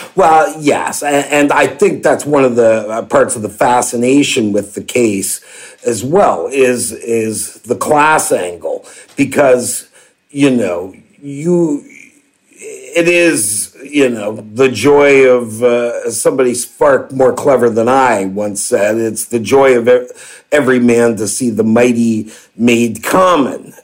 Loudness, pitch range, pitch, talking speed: -12 LUFS, 115-150 Hz, 125 Hz, 140 wpm